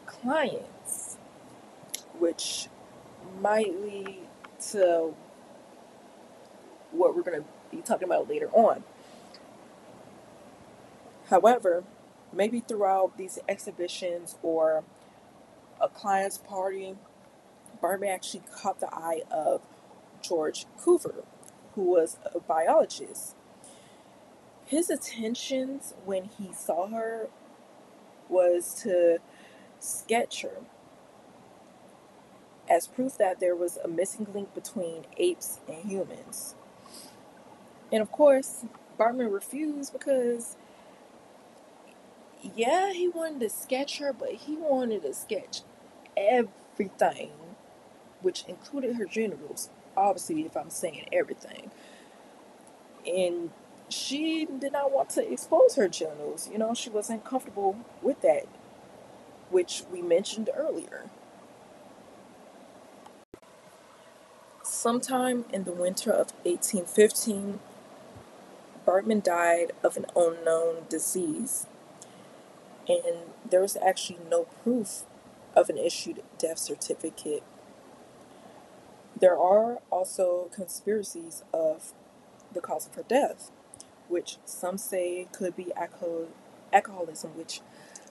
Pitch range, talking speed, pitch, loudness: 185-280 Hz, 100 wpm, 220 Hz, -29 LUFS